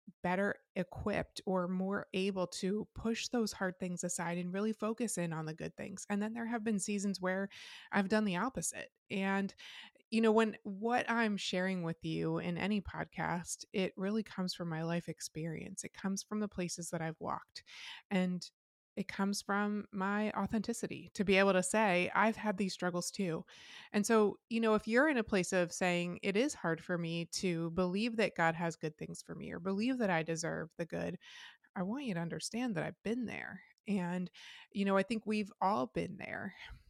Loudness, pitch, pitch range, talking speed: -36 LUFS, 195 Hz, 175-215 Hz, 200 wpm